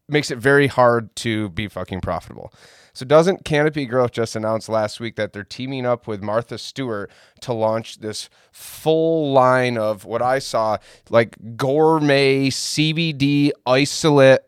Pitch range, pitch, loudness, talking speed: 110-140 Hz, 125 Hz, -19 LUFS, 150 wpm